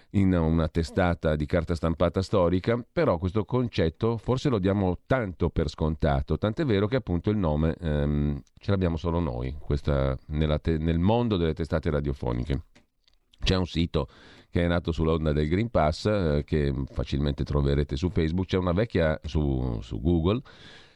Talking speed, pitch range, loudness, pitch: 165 wpm, 75-95 Hz, -27 LUFS, 85 Hz